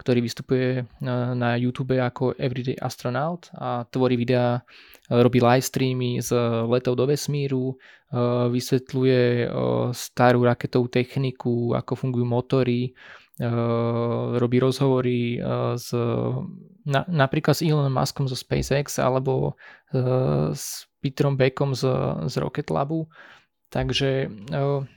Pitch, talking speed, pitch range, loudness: 125 Hz, 105 wpm, 120-135 Hz, -24 LUFS